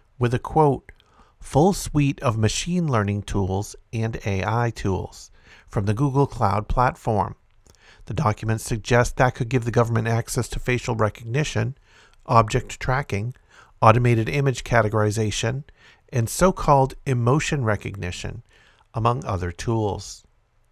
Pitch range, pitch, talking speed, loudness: 105-130 Hz, 115 Hz, 120 wpm, -23 LUFS